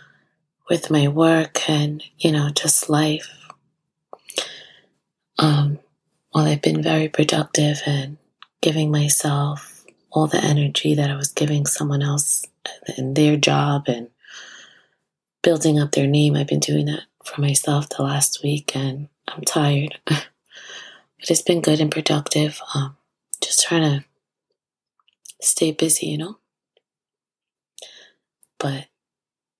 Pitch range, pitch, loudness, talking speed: 145-155 Hz, 150 Hz, -19 LUFS, 125 wpm